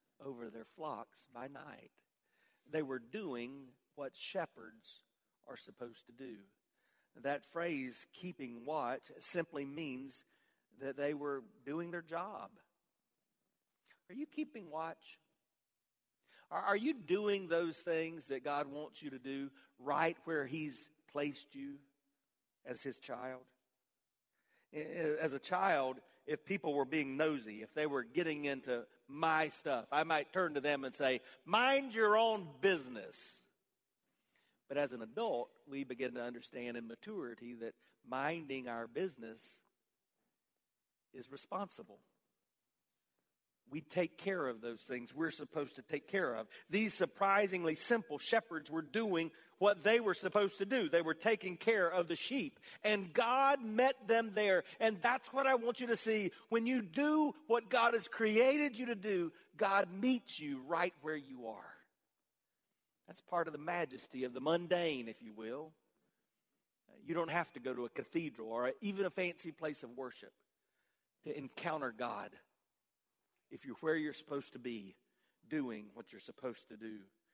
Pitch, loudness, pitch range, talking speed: 155 Hz, -38 LUFS, 130-195 Hz, 150 wpm